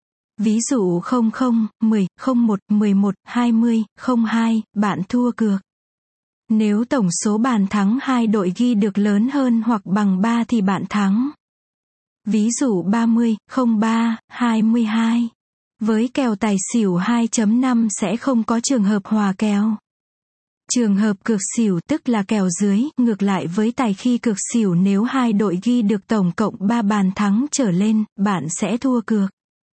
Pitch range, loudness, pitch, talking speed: 205-235 Hz, -19 LUFS, 220 Hz, 155 wpm